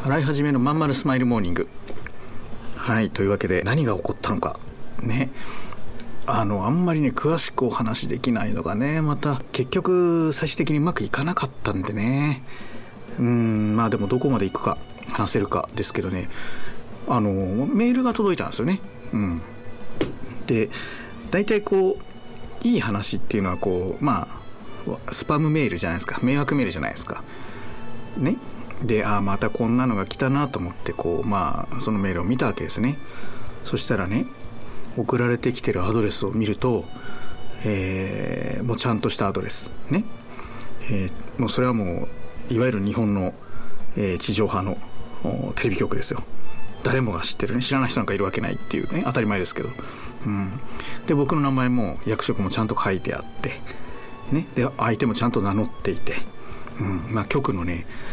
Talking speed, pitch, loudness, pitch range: 325 characters per minute, 120 Hz, -24 LUFS, 105-140 Hz